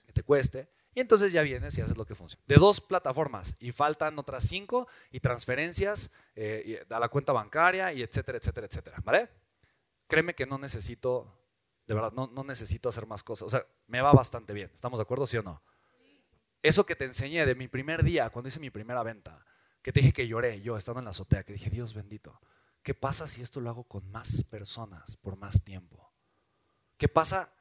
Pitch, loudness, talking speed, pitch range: 125 Hz, -30 LUFS, 210 wpm, 110-140 Hz